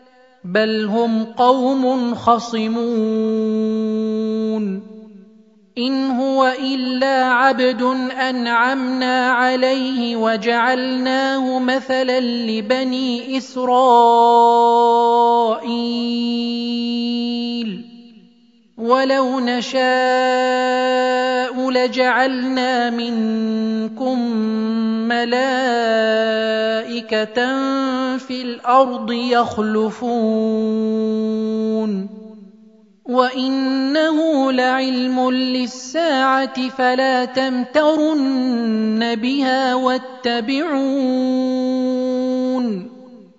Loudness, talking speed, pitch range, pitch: -18 LUFS, 40 wpm, 225-255 Hz, 250 Hz